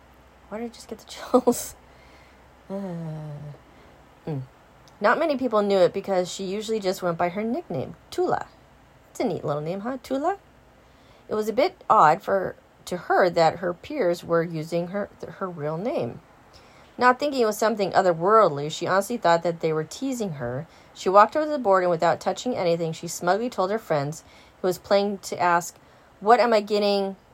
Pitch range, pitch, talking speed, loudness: 165-215 Hz, 185 Hz, 185 wpm, -24 LUFS